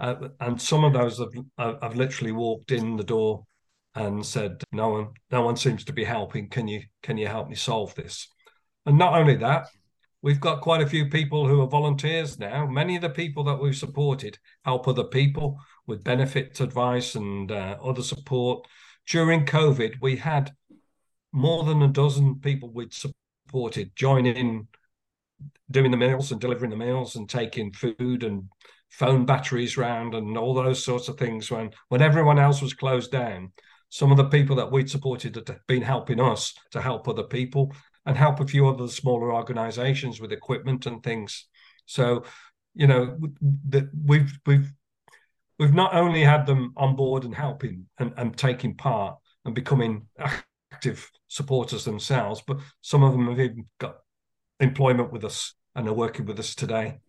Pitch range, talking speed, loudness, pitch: 120-140 Hz, 175 wpm, -24 LUFS, 130 Hz